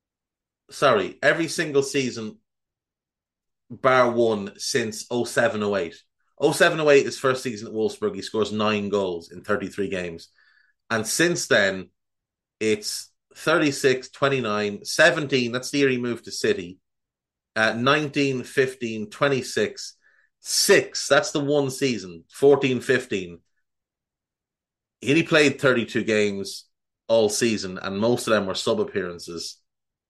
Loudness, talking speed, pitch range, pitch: -22 LUFS, 120 wpm, 100-140 Hz, 115 Hz